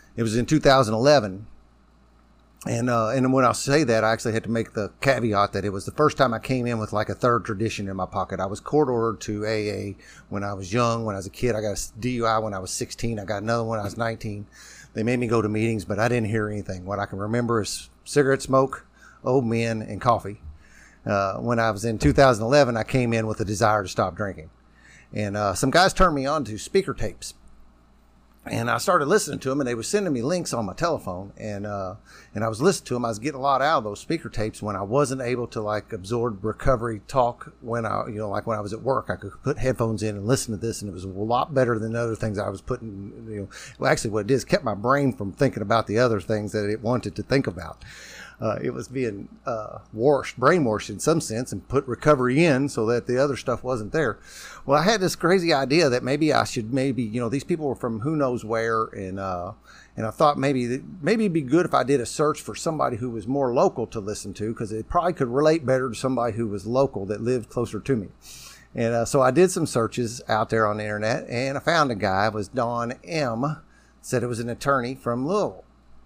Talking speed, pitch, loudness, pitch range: 250 wpm, 115 Hz, -24 LUFS, 105-130 Hz